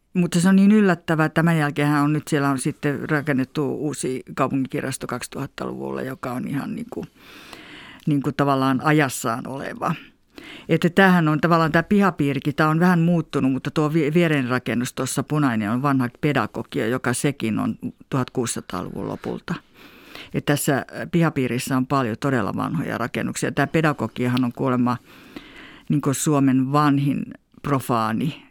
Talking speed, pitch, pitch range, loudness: 140 wpm, 145 Hz, 130-165 Hz, -22 LUFS